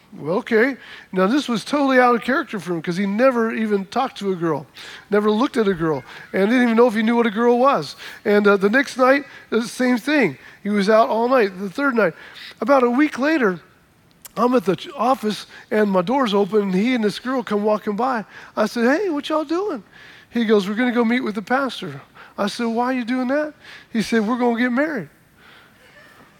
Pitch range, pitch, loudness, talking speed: 205-255 Hz, 230 Hz, -19 LUFS, 230 wpm